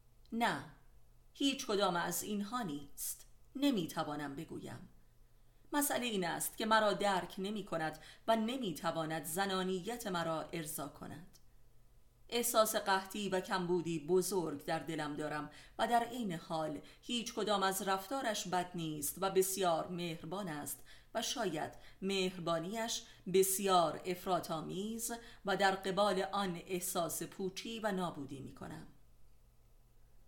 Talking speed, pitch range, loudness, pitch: 120 wpm, 160-205 Hz, -37 LUFS, 185 Hz